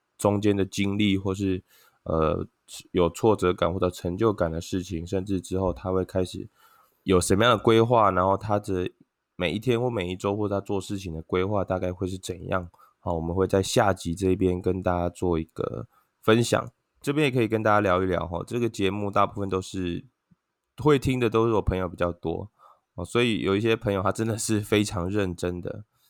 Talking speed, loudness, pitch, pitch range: 290 characters per minute, -26 LUFS, 95 Hz, 90-105 Hz